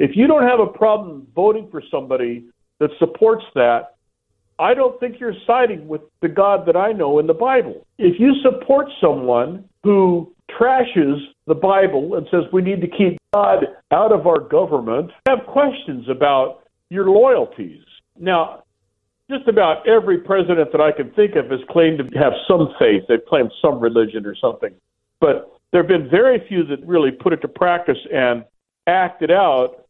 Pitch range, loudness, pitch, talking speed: 145-245 Hz, -17 LUFS, 180 Hz, 175 wpm